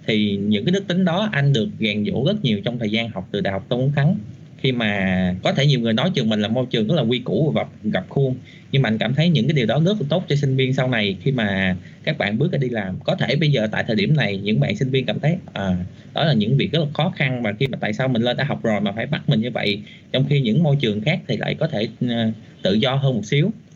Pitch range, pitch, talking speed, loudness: 105-145 Hz, 130 Hz, 305 wpm, -20 LUFS